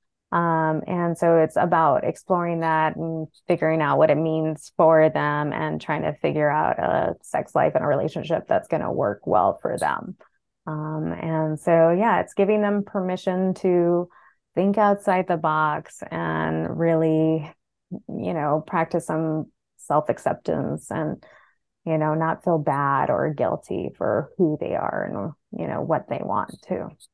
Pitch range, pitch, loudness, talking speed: 155-175 Hz, 160 Hz, -23 LUFS, 160 wpm